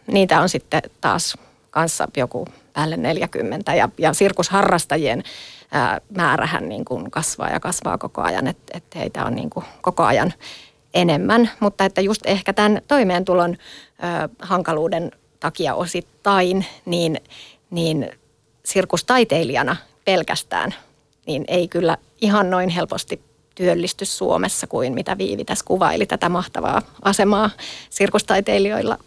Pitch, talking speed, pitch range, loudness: 180 Hz, 120 wpm, 165-200 Hz, -20 LUFS